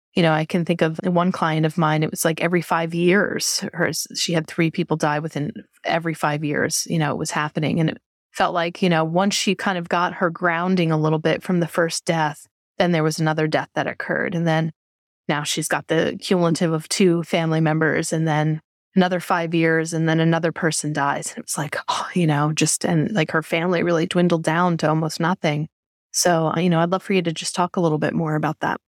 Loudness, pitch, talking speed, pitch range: -21 LUFS, 165 Hz, 235 wpm, 155-175 Hz